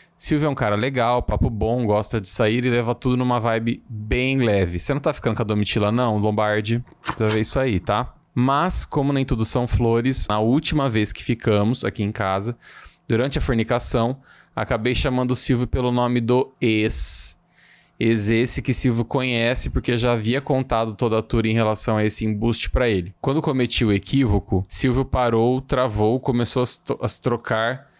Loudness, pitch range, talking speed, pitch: -21 LUFS, 110-130 Hz, 185 wpm, 120 Hz